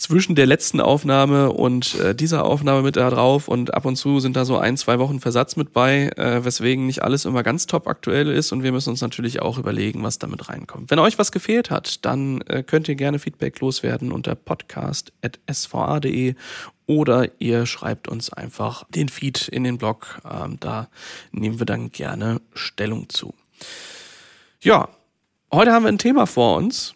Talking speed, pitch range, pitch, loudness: 185 wpm, 120-145 Hz, 130 Hz, -20 LUFS